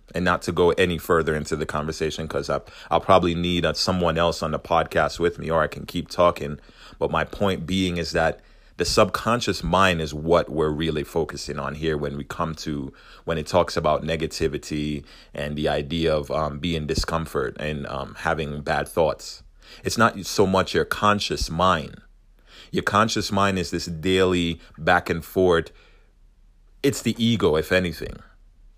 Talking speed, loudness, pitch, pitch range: 175 wpm, -23 LUFS, 80 Hz, 75-90 Hz